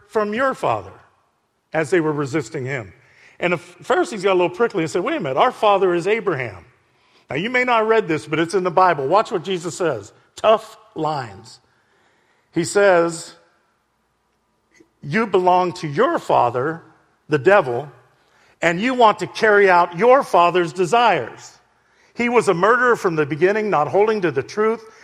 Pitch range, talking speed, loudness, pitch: 170-220 Hz, 175 wpm, -18 LUFS, 190 Hz